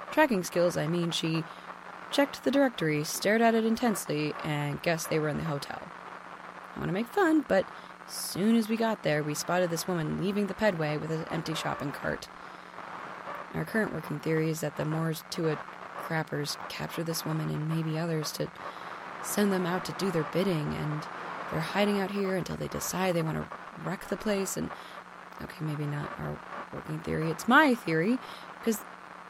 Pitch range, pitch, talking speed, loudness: 155-200 Hz, 170 Hz, 190 wpm, -30 LUFS